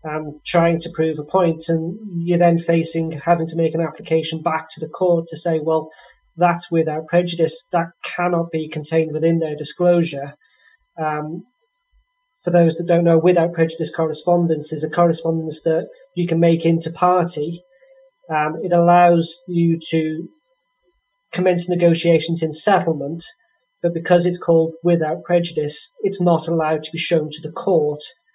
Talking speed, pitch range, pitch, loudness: 160 wpm, 160-175 Hz, 165 Hz, -19 LUFS